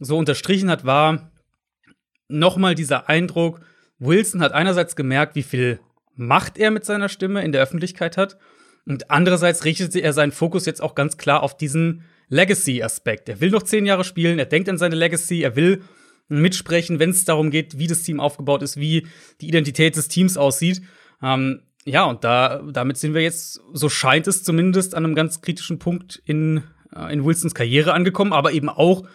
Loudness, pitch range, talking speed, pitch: -19 LUFS, 145-180 Hz, 185 wpm, 160 Hz